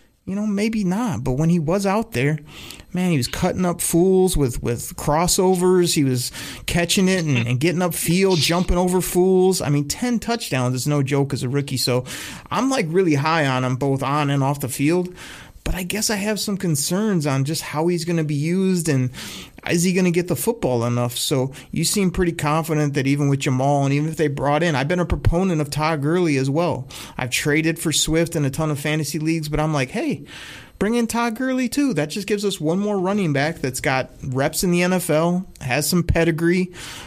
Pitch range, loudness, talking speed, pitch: 140-185 Hz, -20 LUFS, 220 wpm, 165 Hz